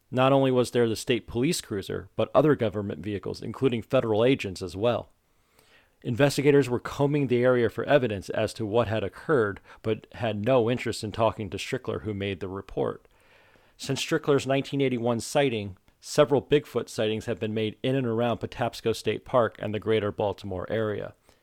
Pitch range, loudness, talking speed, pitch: 105-130 Hz, -27 LUFS, 175 wpm, 115 Hz